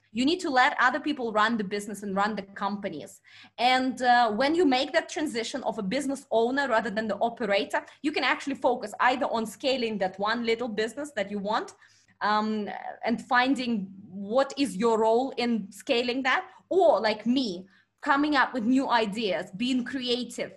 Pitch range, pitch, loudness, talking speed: 215-270 Hz, 240 Hz, -27 LUFS, 180 wpm